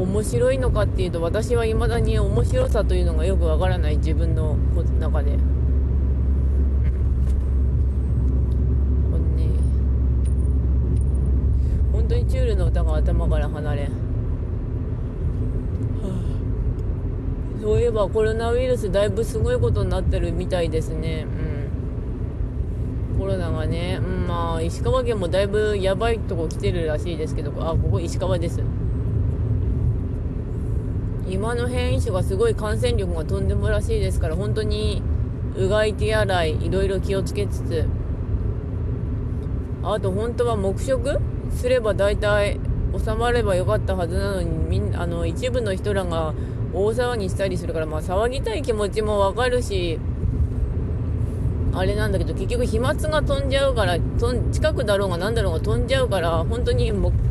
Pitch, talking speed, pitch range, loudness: 95 Hz, 280 characters per minute, 70-110 Hz, -23 LUFS